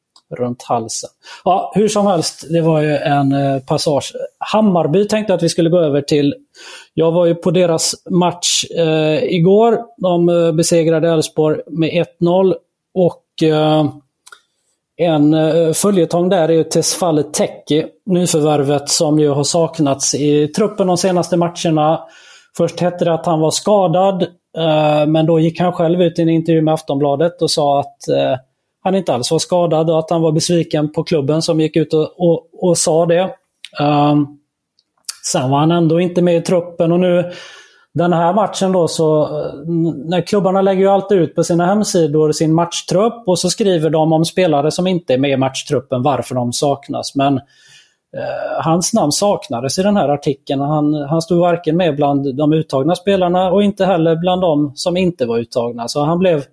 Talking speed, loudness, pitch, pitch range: 175 wpm, -15 LUFS, 165 Hz, 150-180 Hz